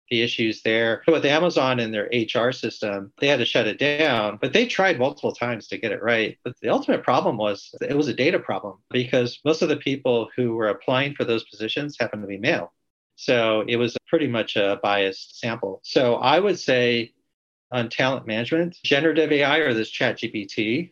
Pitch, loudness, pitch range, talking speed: 120 Hz, -22 LUFS, 110-145 Hz, 205 wpm